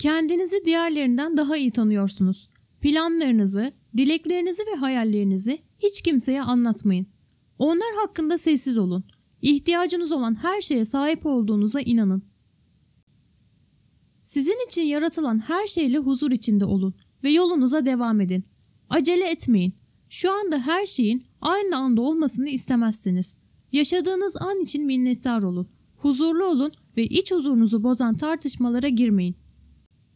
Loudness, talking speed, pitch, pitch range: -22 LUFS, 115 wpm, 280 Hz, 230-330 Hz